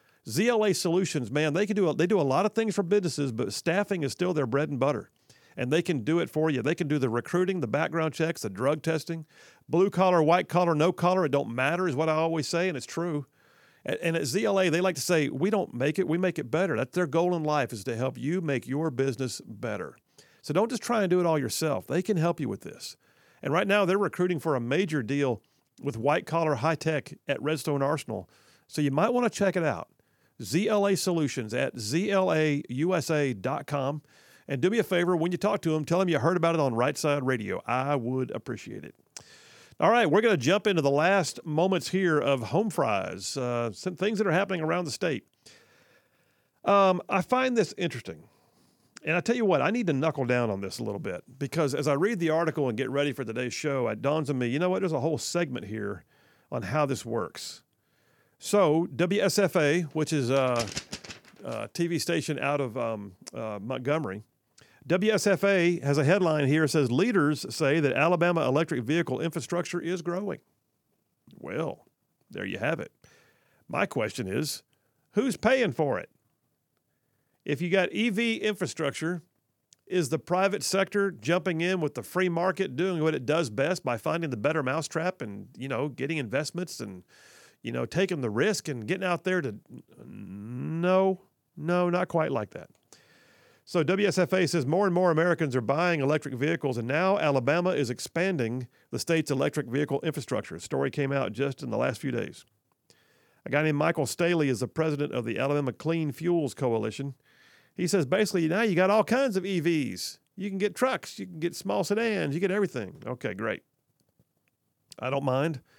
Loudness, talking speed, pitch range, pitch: -27 LUFS, 200 wpm, 140-180 Hz, 160 Hz